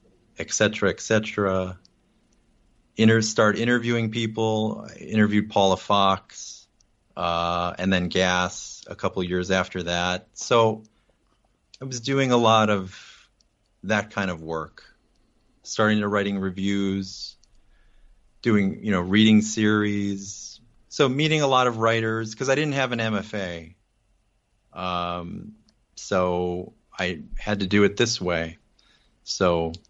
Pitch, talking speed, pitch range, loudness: 105 Hz, 125 wpm, 95-110 Hz, -23 LUFS